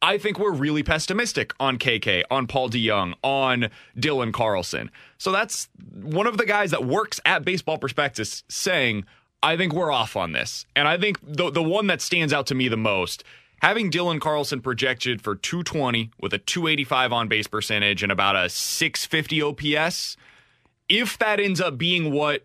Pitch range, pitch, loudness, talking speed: 125-175 Hz, 145 Hz, -23 LUFS, 180 wpm